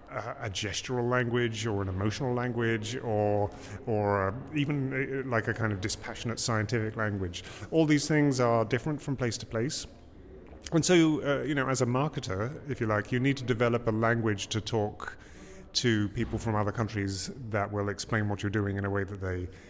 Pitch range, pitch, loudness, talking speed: 105-125 Hz, 115 Hz, -30 LUFS, 185 wpm